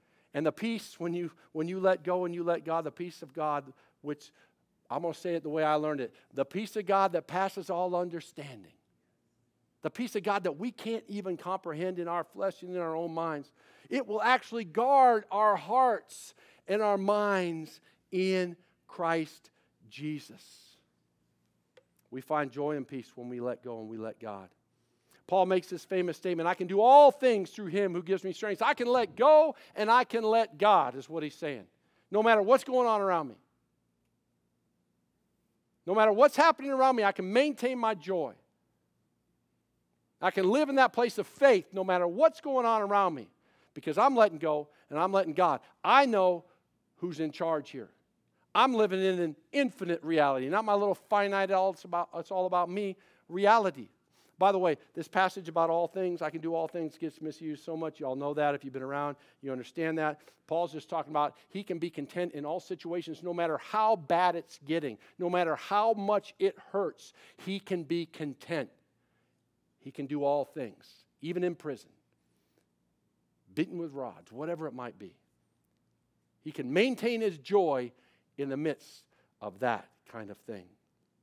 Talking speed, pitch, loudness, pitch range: 190 wpm, 175 Hz, -30 LUFS, 150-200 Hz